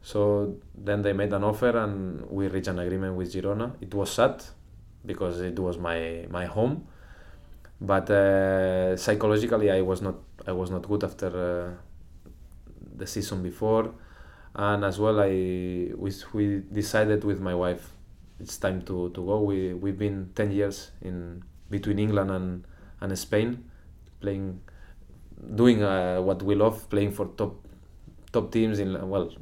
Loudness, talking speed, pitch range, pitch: -27 LUFS, 155 wpm, 90-105 Hz, 95 Hz